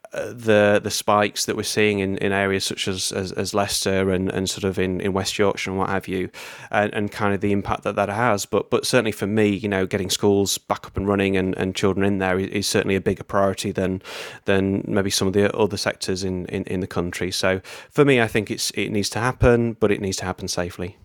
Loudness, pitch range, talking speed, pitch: -22 LUFS, 95-105 Hz, 250 wpm, 100 Hz